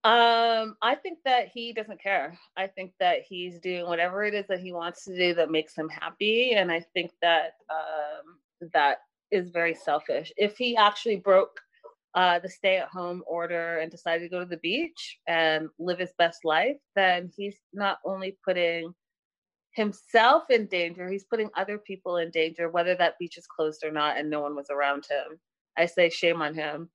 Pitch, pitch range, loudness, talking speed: 180 Hz, 165-205 Hz, -27 LUFS, 195 wpm